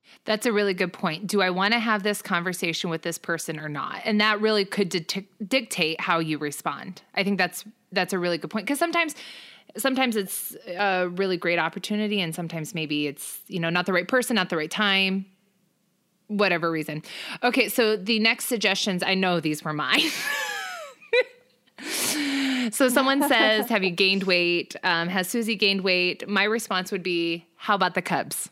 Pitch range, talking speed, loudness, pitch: 175-225 Hz, 185 wpm, -24 LUFS, 195 Hz